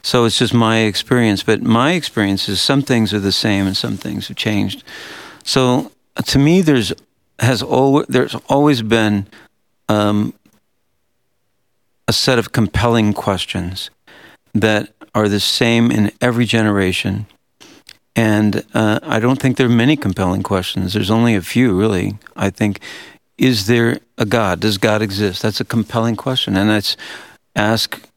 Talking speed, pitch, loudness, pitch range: 155 wpm, 110 Hz, -16 LUFS, 105-120 Hz